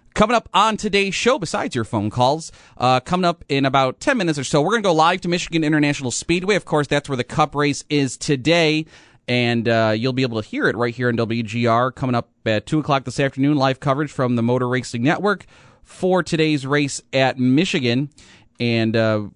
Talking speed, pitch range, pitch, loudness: 215 wpm, 120-155 Hz, 135 Hz, -19 LUFS